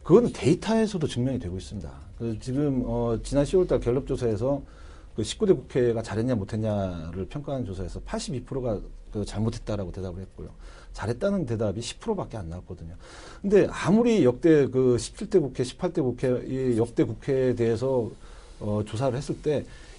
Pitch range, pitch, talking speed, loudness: 100-135 Hz, 120 Hz, 335 characters per minute, -26 LUFS